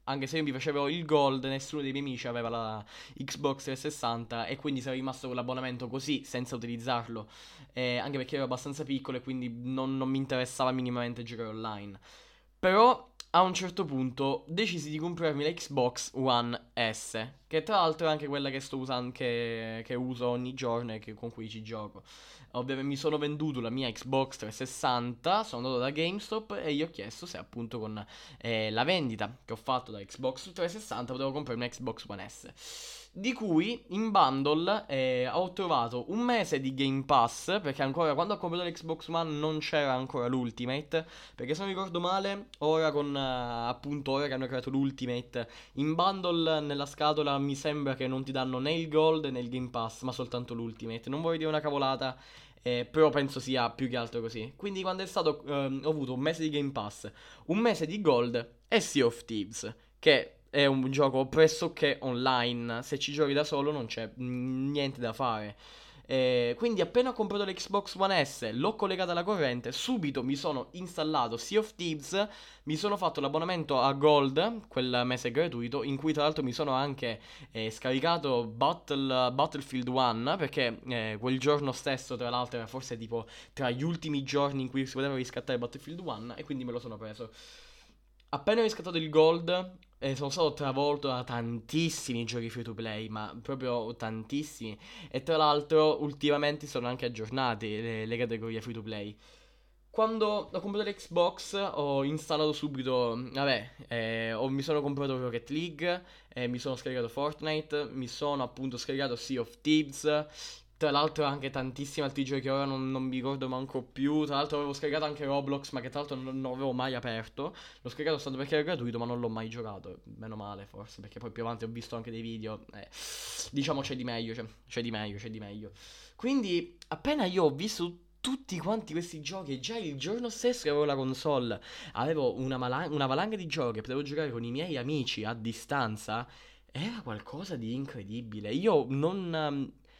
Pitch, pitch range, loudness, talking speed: 135 Hz, 120-155 Hz, -32 LUFS, 185 wpm